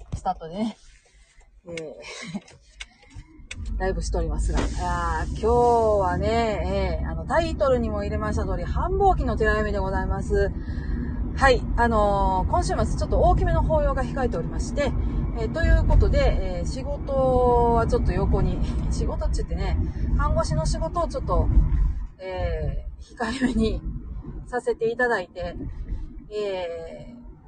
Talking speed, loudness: 280 characters per minute, -24 LUFS